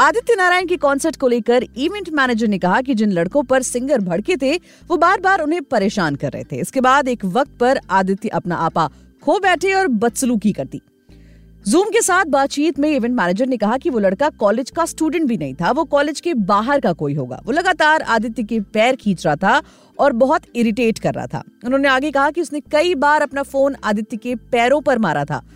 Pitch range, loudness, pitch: 205-300 Hz, -17 LUFS, 255 Hz